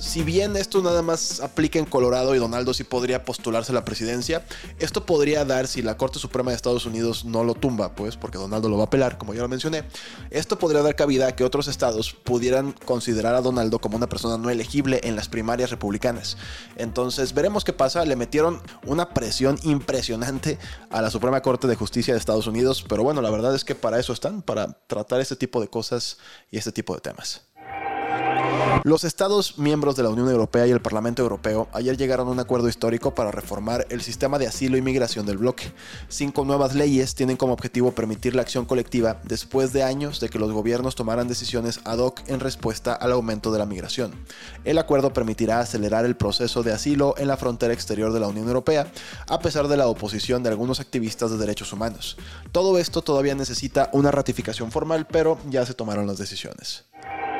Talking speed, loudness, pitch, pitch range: 205 wpm, -24 LUFS, 125 Hz, 115-140 Hz